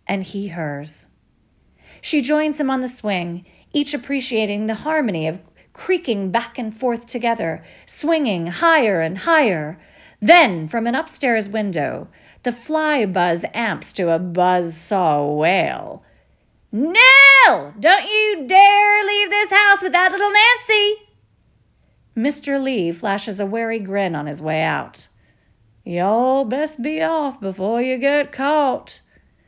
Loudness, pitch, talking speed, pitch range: -16 LUFS, 235 Hz, 135 wpm, 180-300 Hz